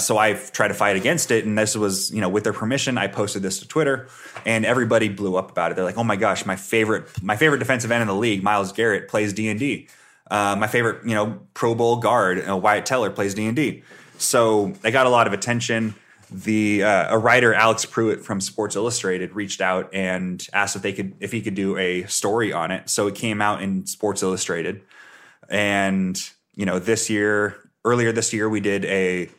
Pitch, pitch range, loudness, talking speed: 105 Hz, 95-115 Hz, -21 LUFS, 220 wpm